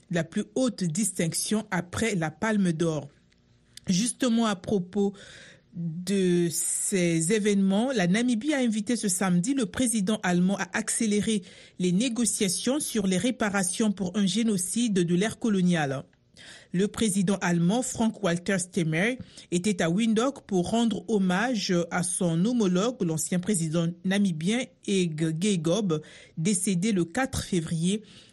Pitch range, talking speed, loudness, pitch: 175-220 Hz, 125 wpm, -26 LUFS, 195 Hz